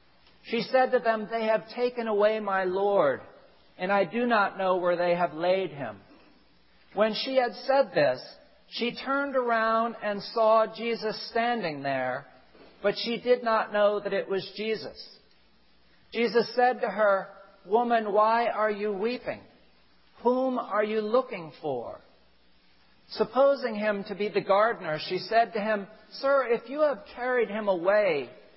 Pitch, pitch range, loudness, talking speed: 215 Hz, 195-240 Hz, -27 LUFS, 155 wpm